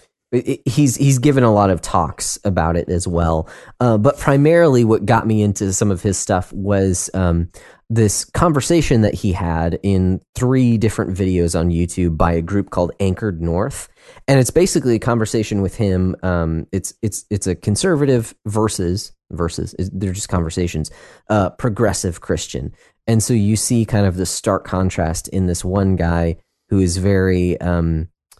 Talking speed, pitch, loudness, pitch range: 170 wpm, 100 Hz, -18 LUFS, 90-115 Hz